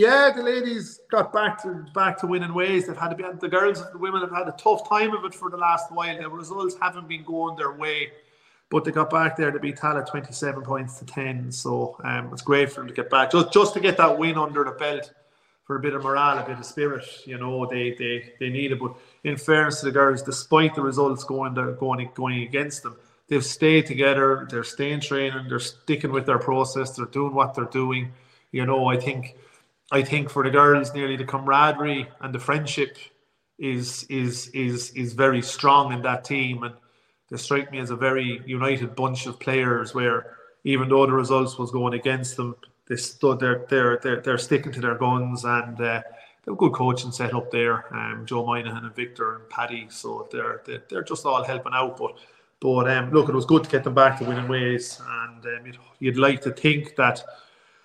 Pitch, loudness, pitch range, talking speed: 135 Hz, -23 LUFS, 125-155 Hz, 225 wpm